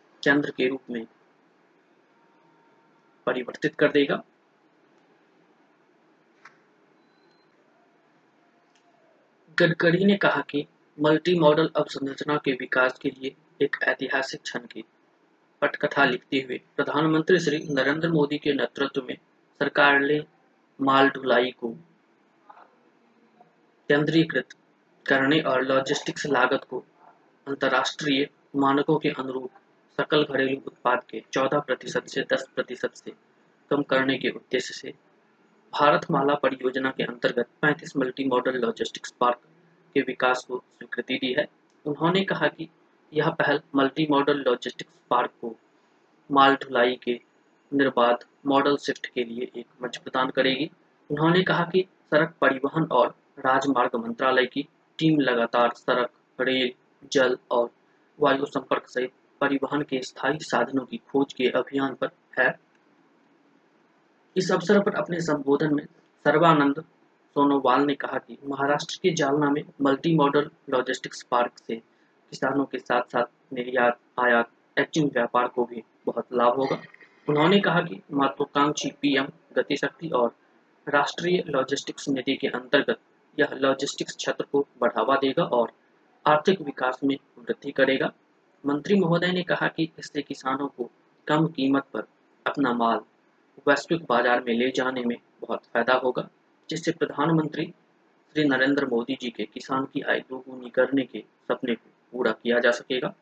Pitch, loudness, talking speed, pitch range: 140 Hz, -25 LUFS, 130 wpm, 130-150 Hz